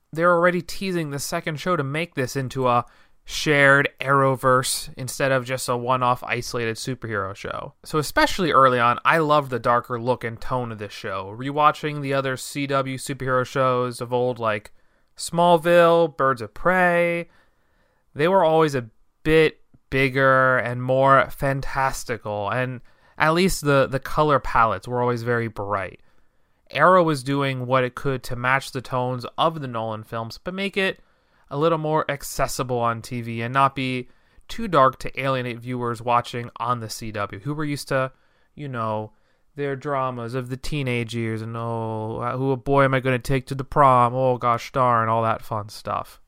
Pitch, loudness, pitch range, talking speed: 130 Hz, -22 LUFS, 120-145 Hz, 175 wpm